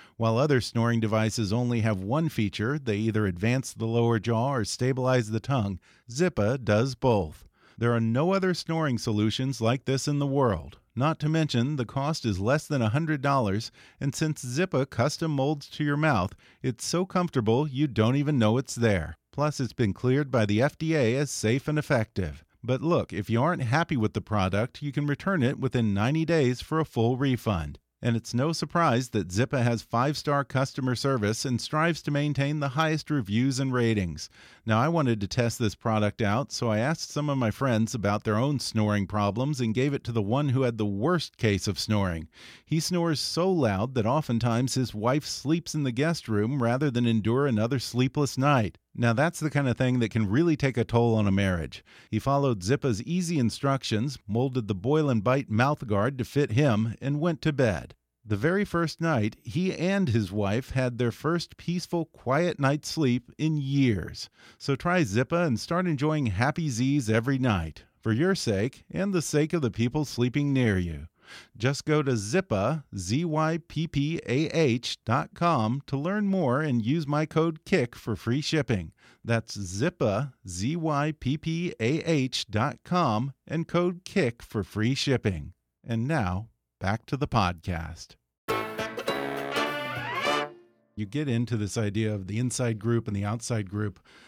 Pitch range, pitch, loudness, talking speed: 110-150 Hz, 125 Hz, -27 LUFS, 185 wpm